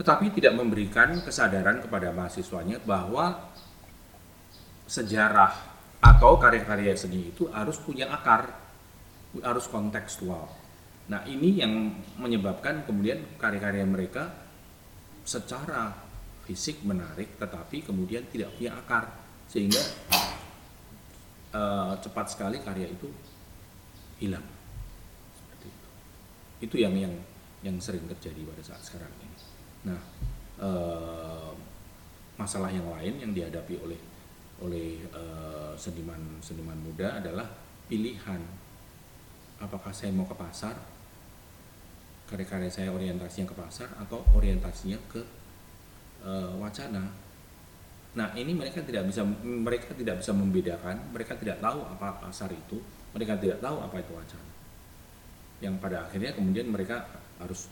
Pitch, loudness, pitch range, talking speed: 95 Hz, -29 LUFS, 90-105 Hz, 110 wpm